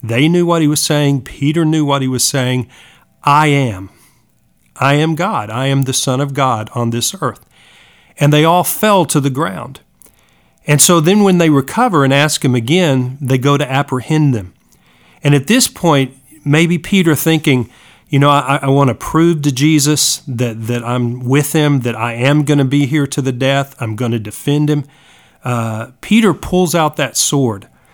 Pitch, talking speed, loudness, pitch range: 140 Hz, 195 wpm, -13 LUFS, 125-155 Hz